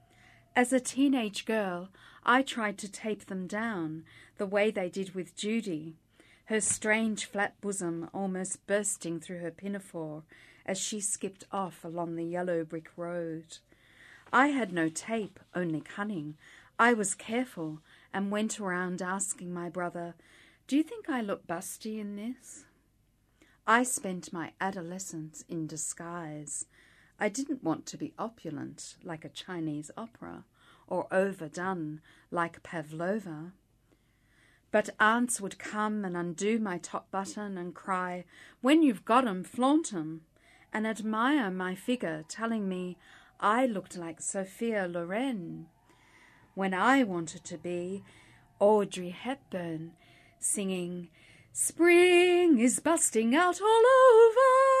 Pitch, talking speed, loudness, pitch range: 190 Hz, 130 wpm, -30 LUFS, 165-220 Hz